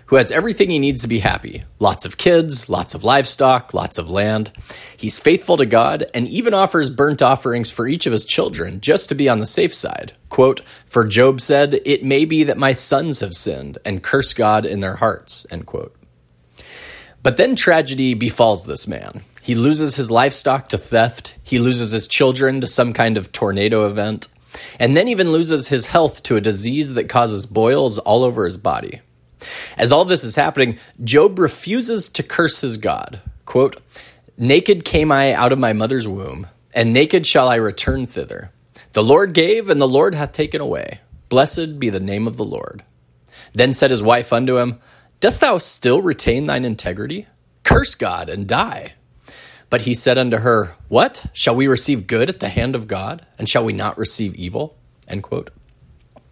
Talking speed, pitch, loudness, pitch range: 190 wpm, 125 Hz, -16 LUFS, 110-145 Hz